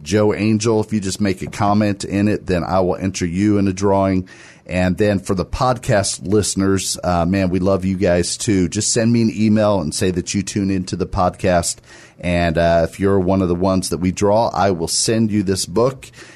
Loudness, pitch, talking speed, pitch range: -18 LUFS, 95 Hz, 225 wpm, 90-105 Hz